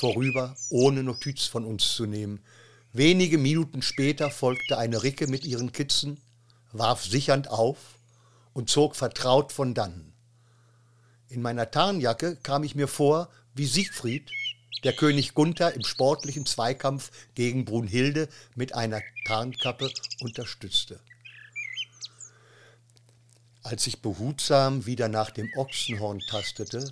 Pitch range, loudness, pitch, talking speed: 115-140 Hz, -27 LUFS, 125 Hz, 120 wpm